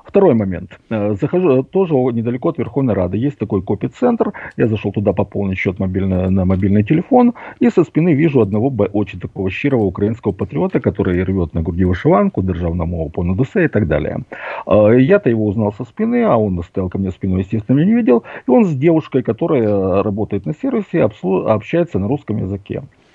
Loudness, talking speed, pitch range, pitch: -16 LUFS, 175 wpm, 95-135 Hz, 105 Hz